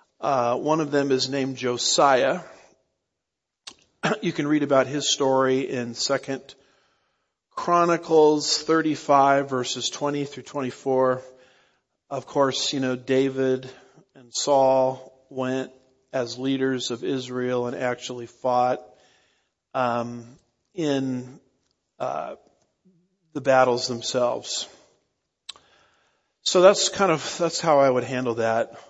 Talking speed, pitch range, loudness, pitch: 110 wpm, 125-145 Hz, -23 LUFS, 130 Hz